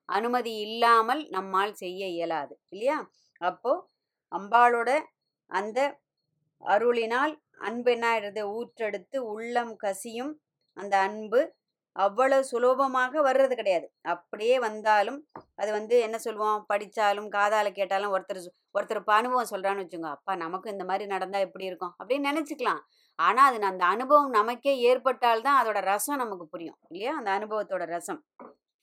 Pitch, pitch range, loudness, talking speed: 215 Hz, 195-255 Hz, -27 LUFS, 125 wpm